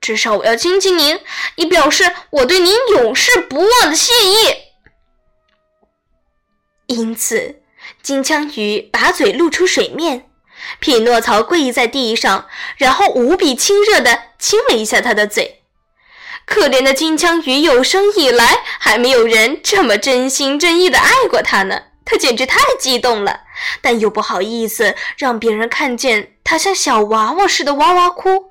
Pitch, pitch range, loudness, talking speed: 310 Hz, 240-380 Hz, -12 LUFS, 220 characters per minute